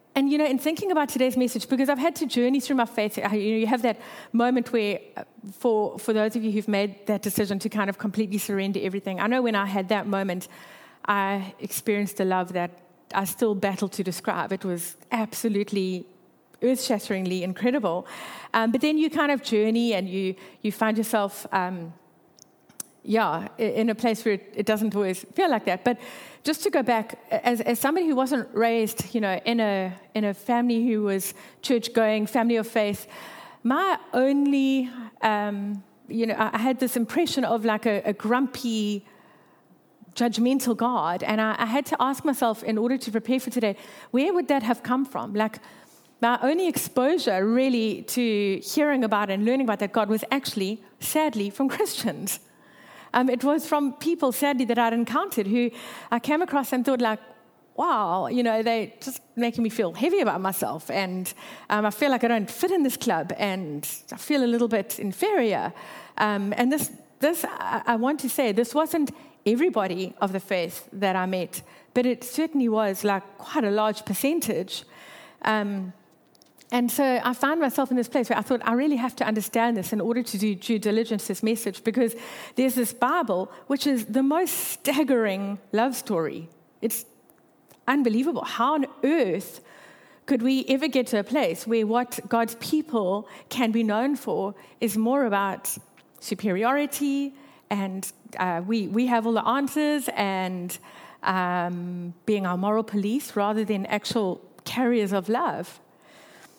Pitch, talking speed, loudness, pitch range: 230 Hz, 175 wpm, -25 LUFS, 205-260 Hz